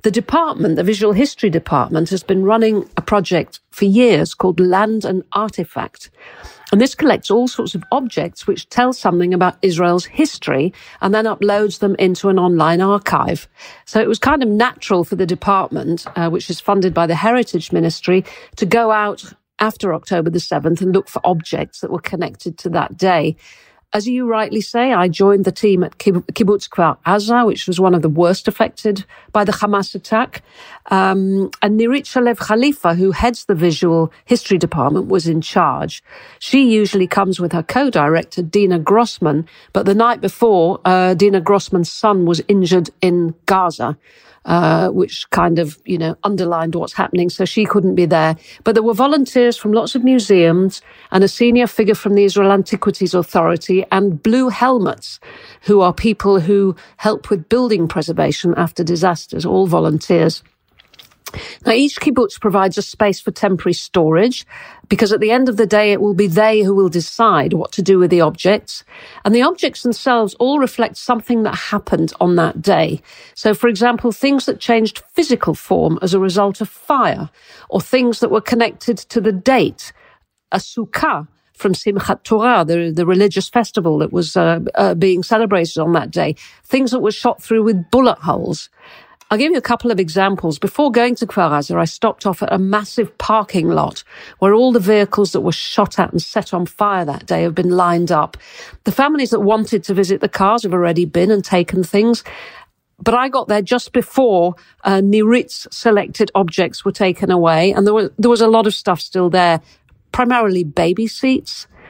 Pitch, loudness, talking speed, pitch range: 200 Hz, -15 LUFS, 185 wpm, 180-225 Hz